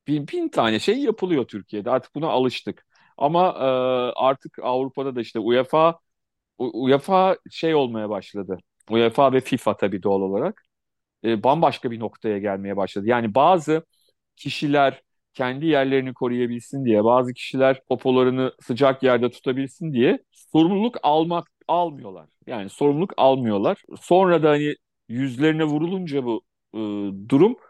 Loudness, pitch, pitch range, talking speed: -22 LUFS, 130 Hz, 115-150 Hz, 130 wpm